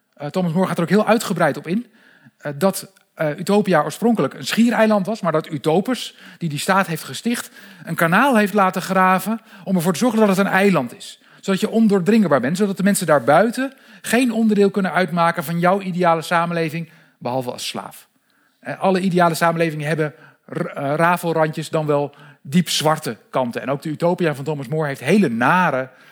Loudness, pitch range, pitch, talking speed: -19 LUFS, 160-205 Hz, 185 Hz, 175 wpm